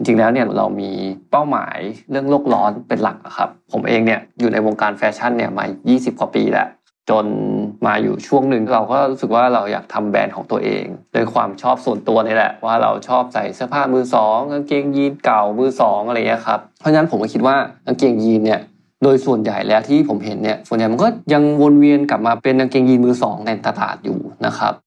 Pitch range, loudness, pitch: 110-140 Hz, -17 LUFS, 125 Hz